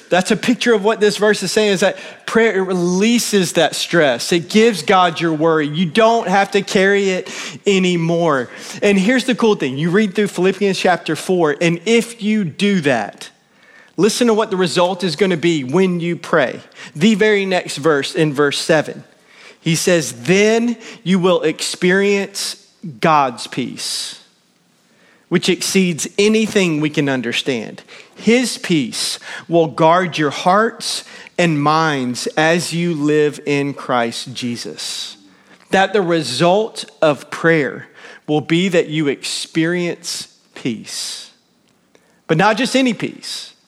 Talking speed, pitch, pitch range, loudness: 145 wpm, 180 Hz, 160-210 Hz, -16 LUFS